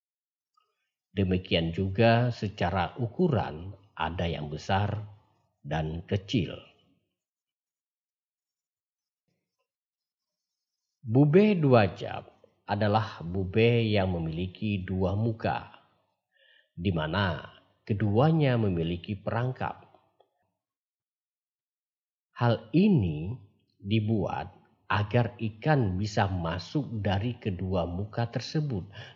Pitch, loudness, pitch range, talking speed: 105 Hz, -28 LUFS, 95-120 Hz, 70 wpm